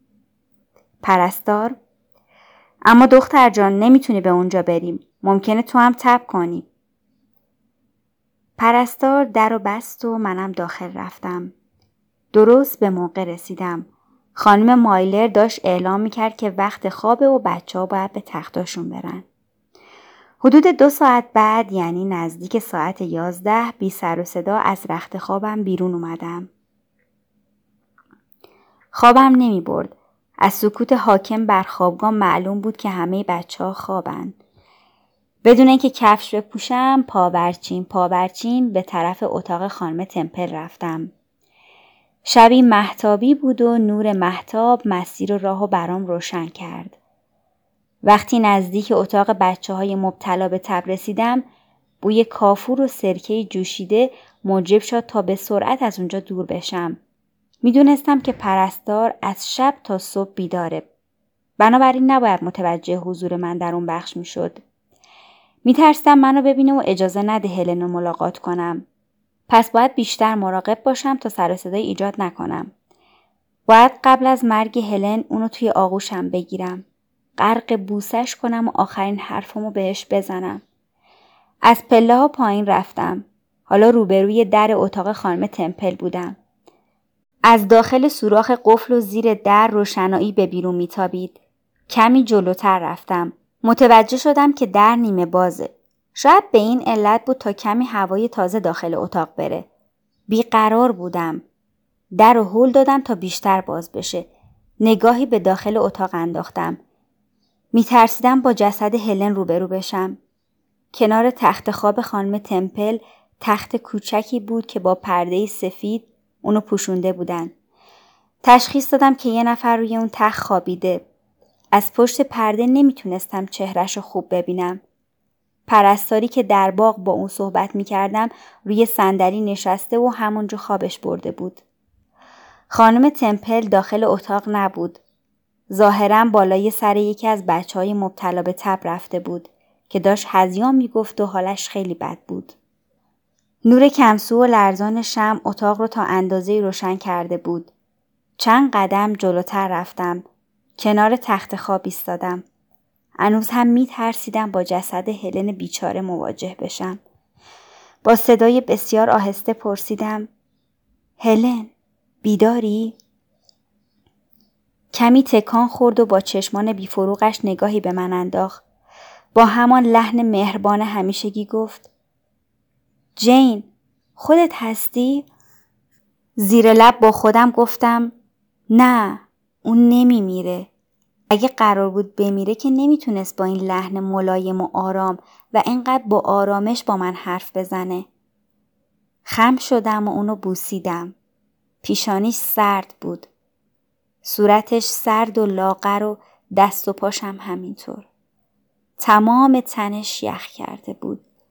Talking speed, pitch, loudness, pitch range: 125 wpm, 210 Hz, -17 LUFS, 185-230 Hz